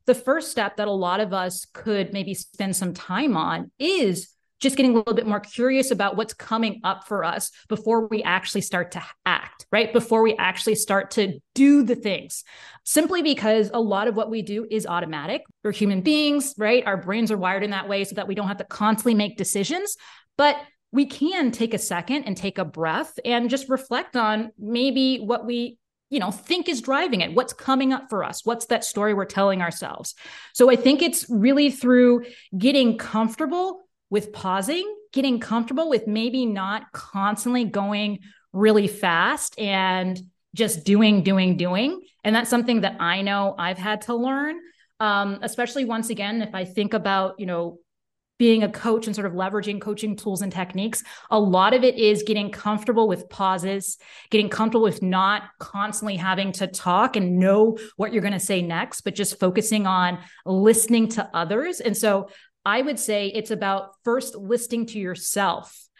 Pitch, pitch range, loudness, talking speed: 215 Hz, 195-240 Hz, -23 LUFS, 185 wpm